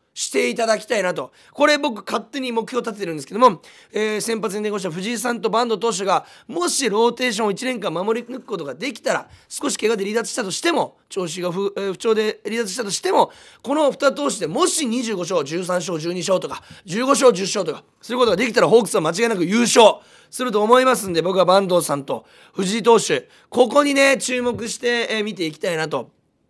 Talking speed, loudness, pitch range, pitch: 400 characters per minute, -20 LUFS, 200-255 Hz, 230 Hz